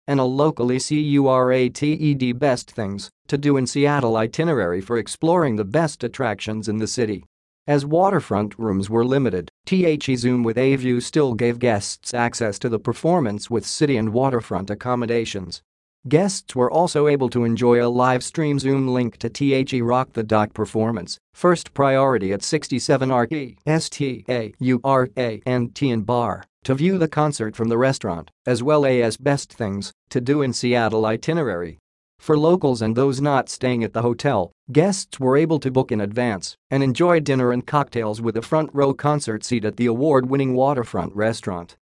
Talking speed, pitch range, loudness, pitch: 185 wpm, 115-145 Hz, -21 LUFS, 125 Hz